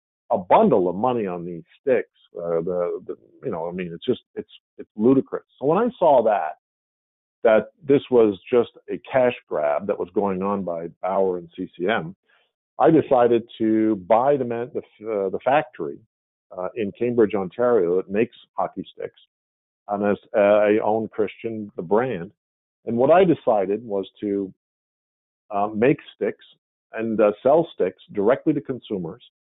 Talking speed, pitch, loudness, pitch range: 165 wpm, 110 Hz, -22 LUFS, 95-130 Hz